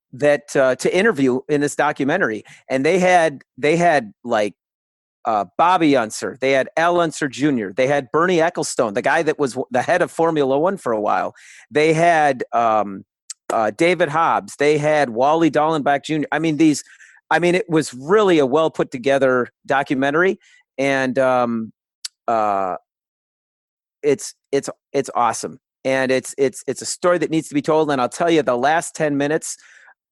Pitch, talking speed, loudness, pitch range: 145 Hz, 175 wpm, -18 LUFS, 130-160 Hz